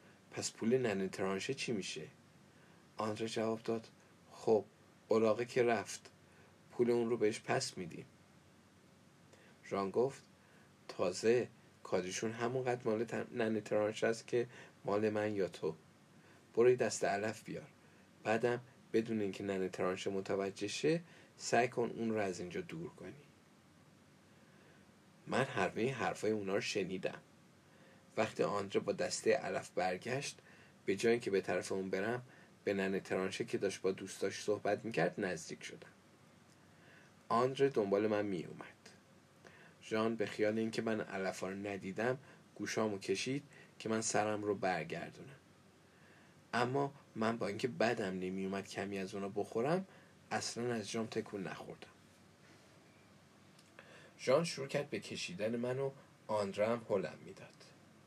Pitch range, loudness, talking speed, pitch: 100-120 Hz, -38 LUFS, 135 wpm, 110 Hz